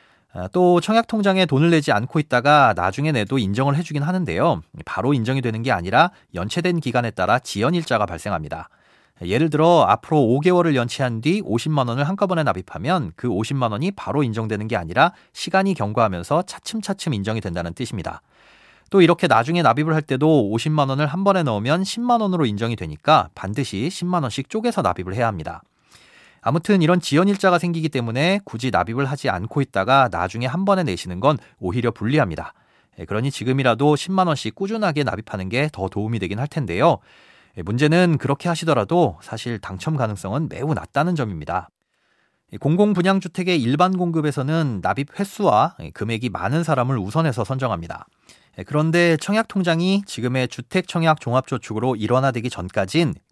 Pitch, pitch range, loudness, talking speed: 140 Hz, 115-175 Hz, -20 LUFS, 380 characters per minute